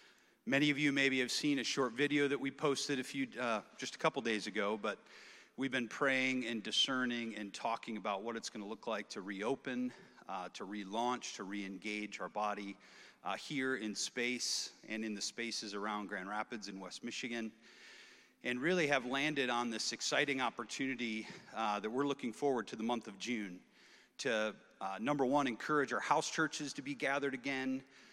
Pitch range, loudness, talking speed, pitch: 110-135 Hz, -37 LUFS, 190 wpm, 120 Hz